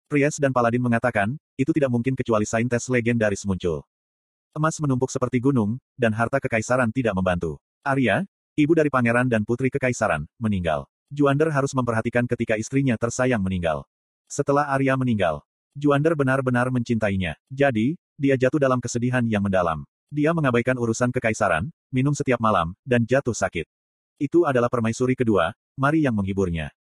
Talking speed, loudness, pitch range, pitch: 145 wpm, -23 LUFS, 110-135 Hz, 120 Hz